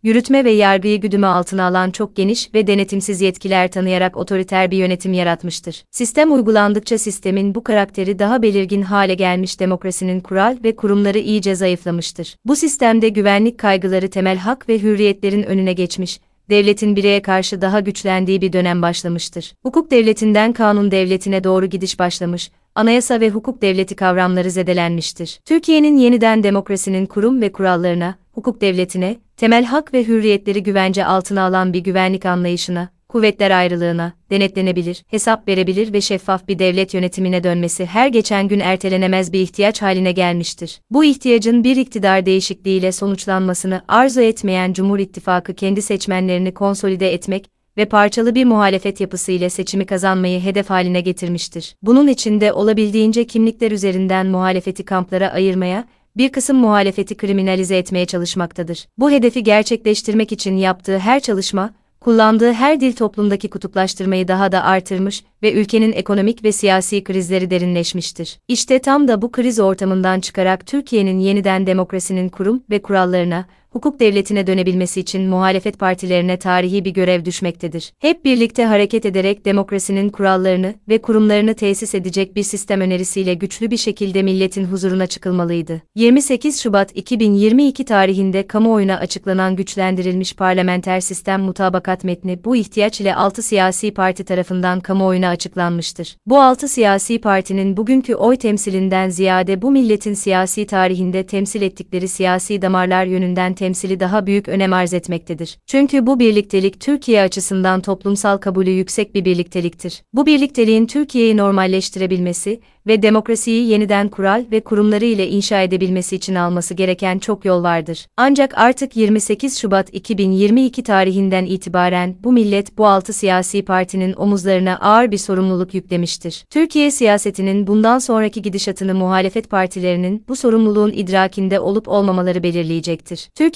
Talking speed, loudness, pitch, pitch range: 135 wpm, -16 LUFS, 195 Hz, 185-215 Hz